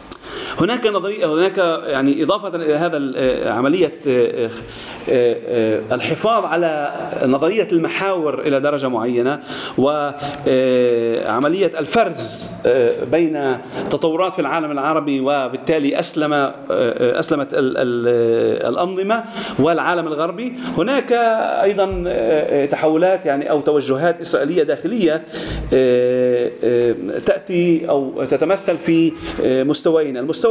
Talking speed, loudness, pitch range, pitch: 85 wpm, -18 LUFS, 140-195 Hz, 160 Hz